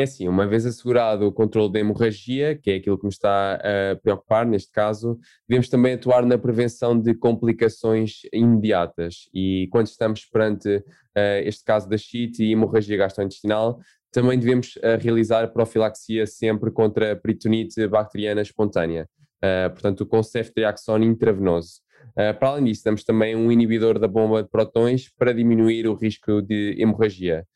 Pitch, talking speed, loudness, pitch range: 110 Hz, 160 wpm, -21 LUFS, 105-115 Hz